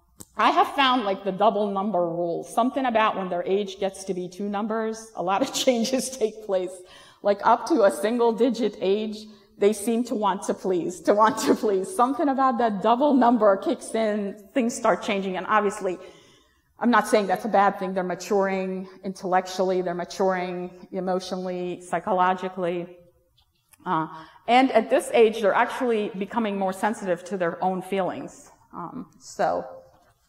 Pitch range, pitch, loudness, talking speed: 185-225 Hz, 200 Hz, -24 LUFS, 165 wpm